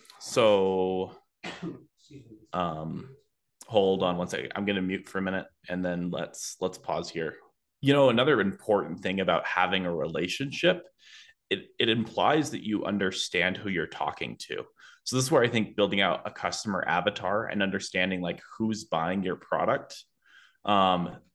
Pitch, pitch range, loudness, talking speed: 100 Hz, 90-115 Hz, -28 LUFS, 155 wpm